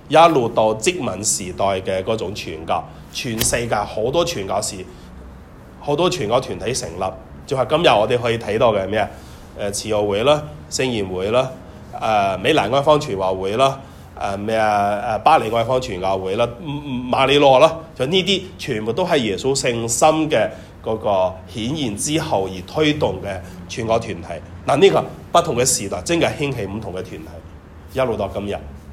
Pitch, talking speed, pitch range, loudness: 110 Hz, 265 characters per minute, 95-135 Hz, -19 LUFS